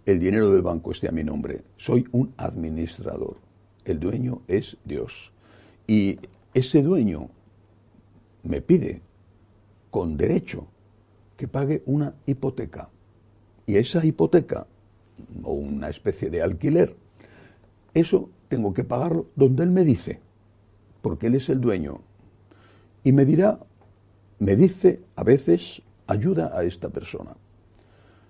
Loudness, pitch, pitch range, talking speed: -23 LUFS, 105 Hz, 100-130 Hz, 125 wpm